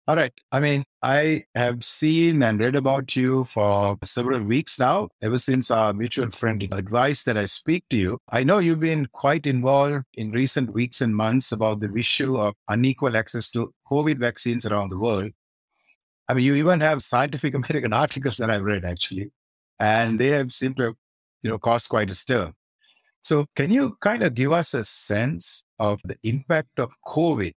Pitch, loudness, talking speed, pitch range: 125 Hz, -23 LUFS, 195 wpm, 110-140 Hz